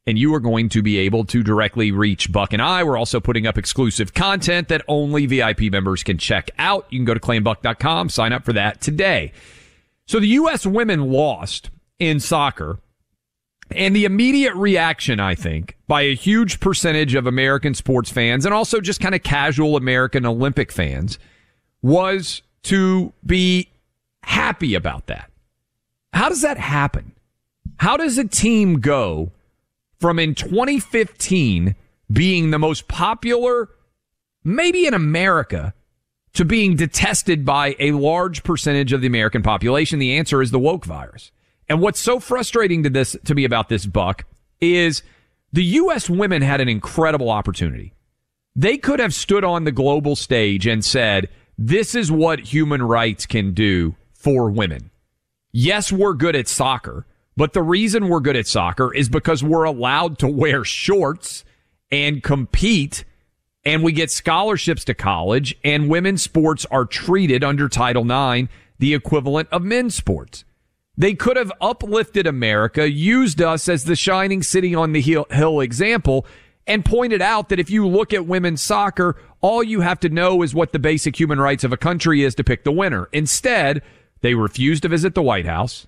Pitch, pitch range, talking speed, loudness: 145 Hz, 115-180 Hz, 165 wpm, -18 LUFS